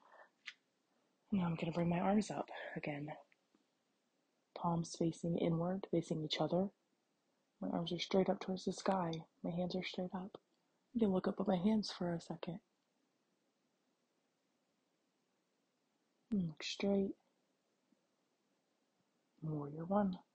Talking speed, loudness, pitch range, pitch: 125 wpm, -40 LUFS, 170-195 Hz, 180 Hz